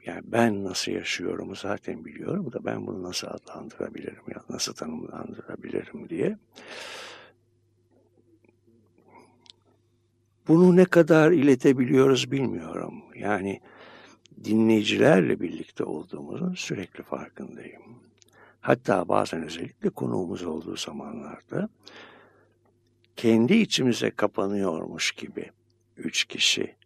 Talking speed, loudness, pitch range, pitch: 85 wpm, -25 LUFS, 110-130 Hz, 115 Hz